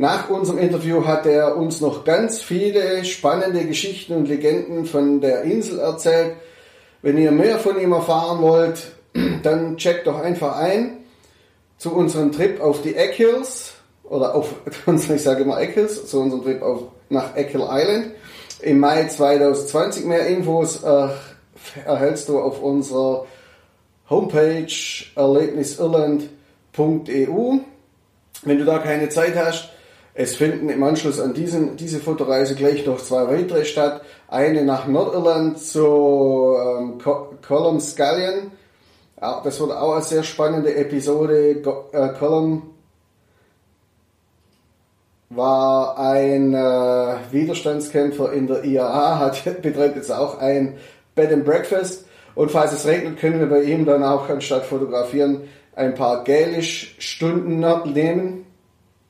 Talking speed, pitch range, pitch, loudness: 135 wpm, 135-165 Hz, 150 Hz, -19 LUFS